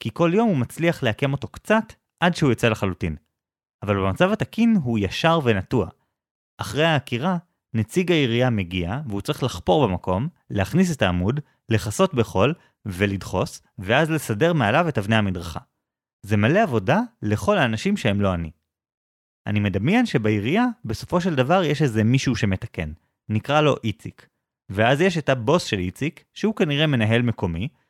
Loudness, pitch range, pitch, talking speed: -22 LUFS, 100-160 Hz, 115 Hz, 150 wpm